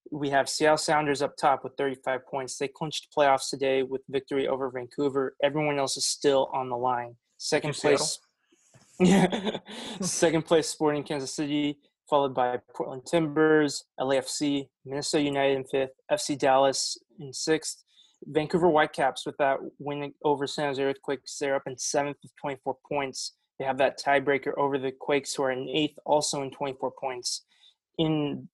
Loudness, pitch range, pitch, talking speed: -27 LUFS, 135-150 Hz, 140 Hz, 160 wpm